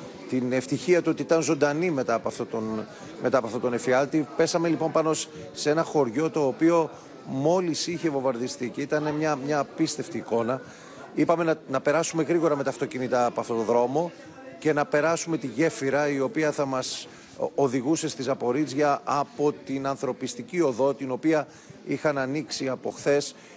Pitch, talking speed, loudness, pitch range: 145 Hz, 170 wpm, -26 LUFS, 130-160 Hz